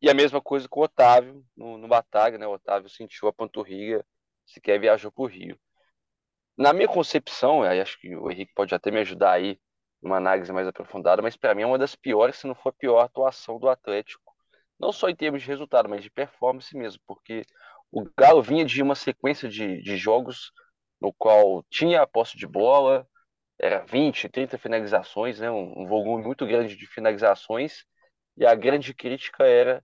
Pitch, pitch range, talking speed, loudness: 120 Hz, 105-140 Hz, 195 wpm, -23 LUFS